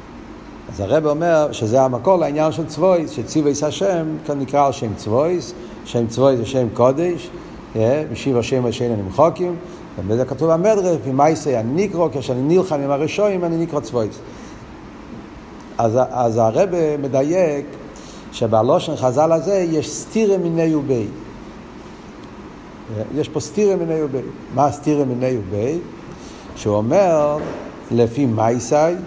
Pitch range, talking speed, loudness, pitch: 125-165 Hz, 130 wpm, -18 LUFS, 150 Hz